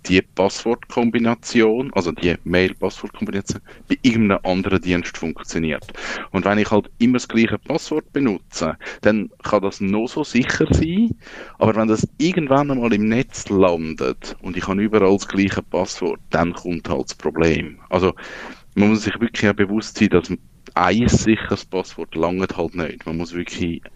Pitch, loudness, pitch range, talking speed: 100 Hz, -20 LUFS, 90-115 Hz, 160 wpm